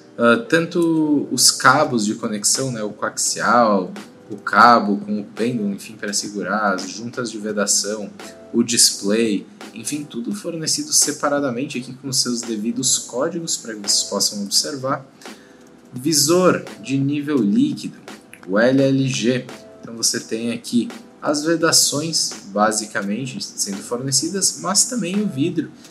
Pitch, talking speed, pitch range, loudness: 130 Hz, 130 wpm, 110-160 Hz, -18 LUFS